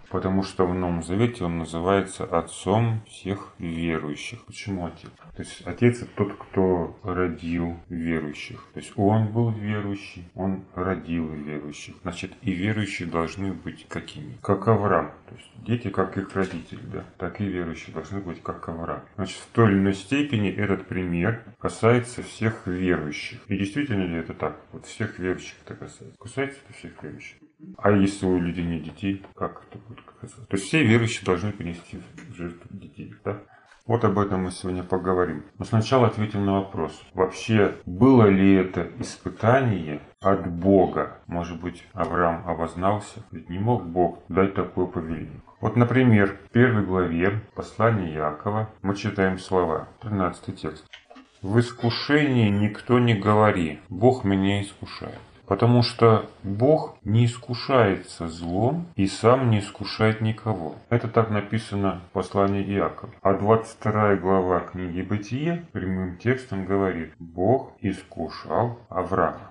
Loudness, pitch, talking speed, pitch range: -24 LUFS, 95 Hz, 145 wpm, 90-110 Hz